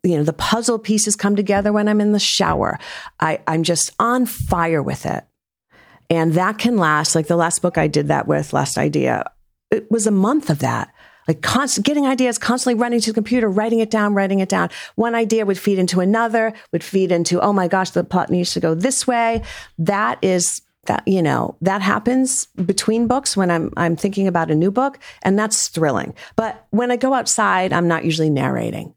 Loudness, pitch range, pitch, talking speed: -18 LUFS, 170-230 Hz, 200 Hz, 210 wpm